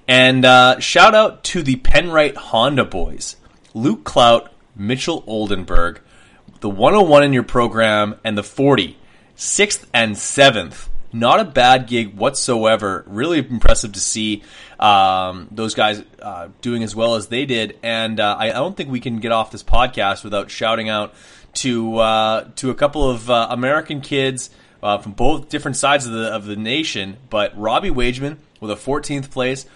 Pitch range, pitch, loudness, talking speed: 110-135 Hz, 115 Hz, -16 LUFS, 165 wpm